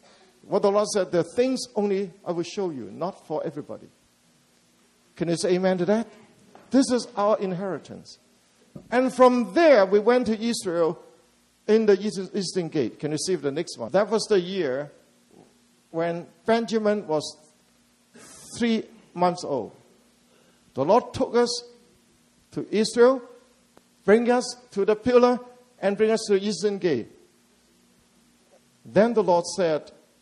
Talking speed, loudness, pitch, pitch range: 145 wpm, -24 LUFS, 205 Hz, 180-235 Hz